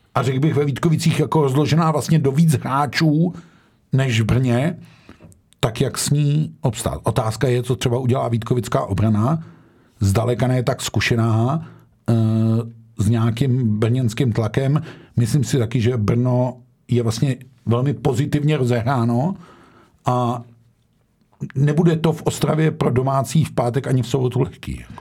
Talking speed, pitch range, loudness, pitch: 135 wpm, 115-150 Hz, -19 LUFS, 130 Hz